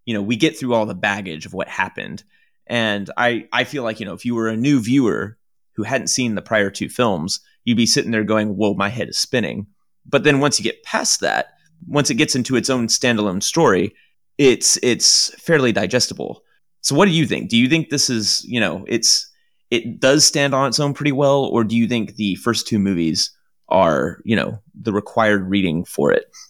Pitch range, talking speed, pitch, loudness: 110-145 Hz, 220 wpm, 120 Hz, -18 LUFS